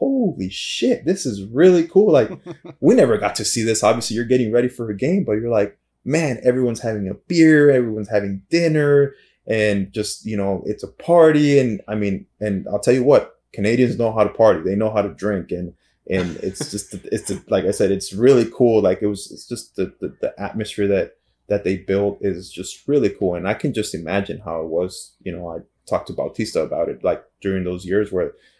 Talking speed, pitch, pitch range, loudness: 220 wpm, 105 Hz, 100-125 Hz, -19 LUFS